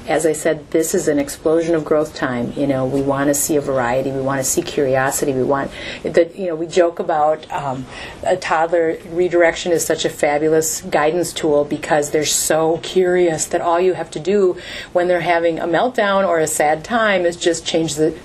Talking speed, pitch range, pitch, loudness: 210 wpm, 150-170 Hz, 160 Hz, -17 LUFS